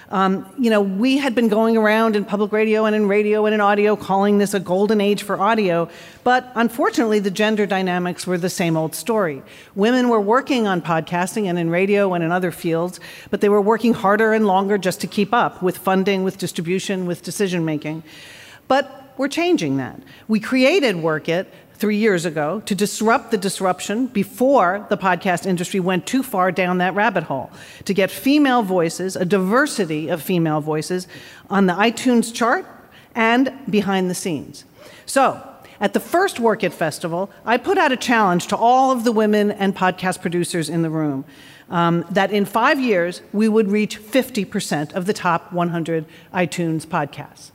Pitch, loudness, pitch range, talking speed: 200 Hz, -19 LUFS, 180-220 Hz, 180 wpm